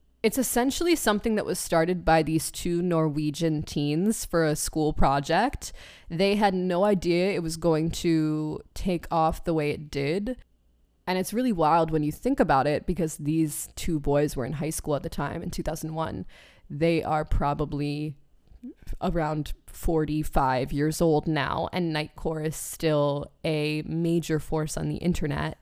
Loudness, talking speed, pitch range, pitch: -26 LUFS, 160 wpm, 150-175 Hz, 160 Hz